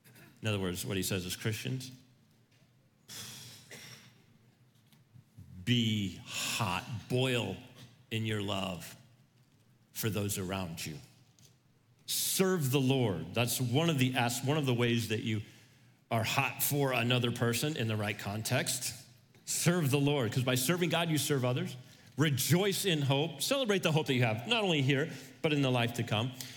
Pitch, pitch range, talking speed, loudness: 125 Hz, 115-140 Hz, 155 wpm, -32 LUFS